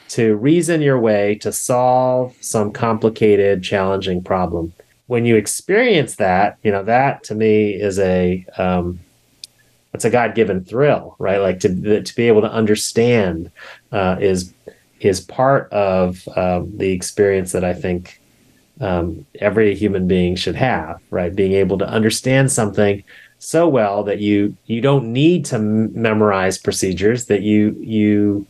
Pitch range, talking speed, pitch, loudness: 95-115 Hz, 150 wpm, 105 Hz, -17 LUFS